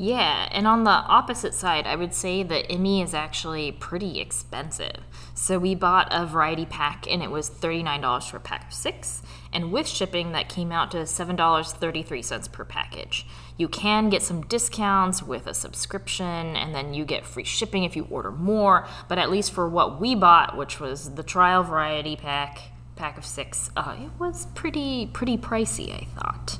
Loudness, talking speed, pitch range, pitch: -24 LUFS, 185 wpm, 145-190 Hz, 165 Hz